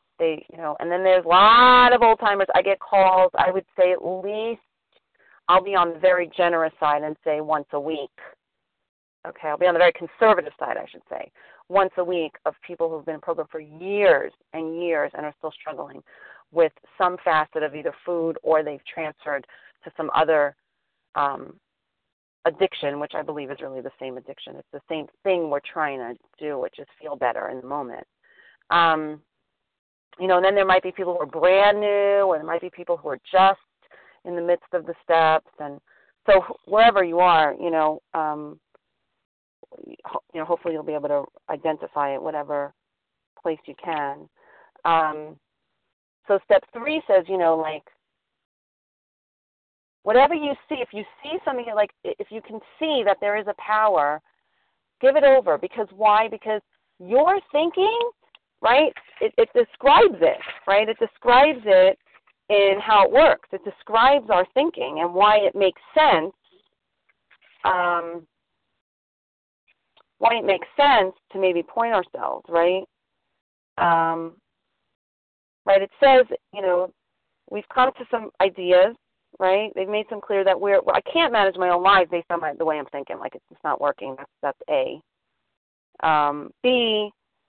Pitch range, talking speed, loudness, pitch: 160-215 Hz, 170 wpm, -21 LUFS, 185 Hz